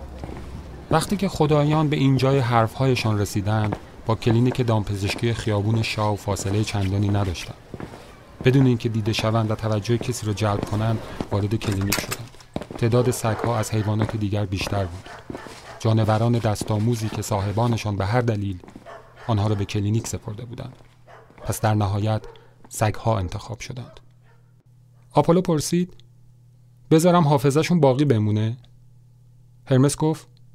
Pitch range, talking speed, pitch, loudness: 105-125 Hz, 125 wpm, 115 Hz, -22 LUFS